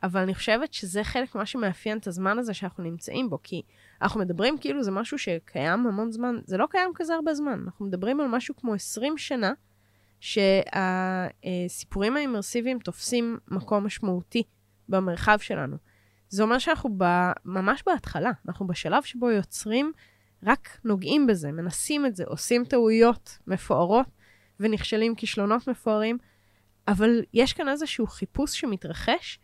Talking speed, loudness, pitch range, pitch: 140 wpm, -27 LUFS, 185-245 Hz, 215 Hz